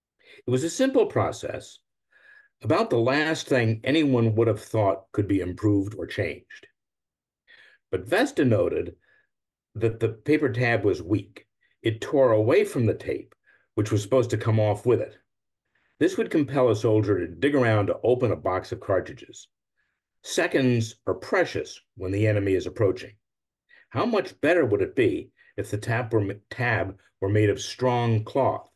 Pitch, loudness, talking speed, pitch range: 115 Hz, -25 LUFS, 160 wpm, 105-125 Hz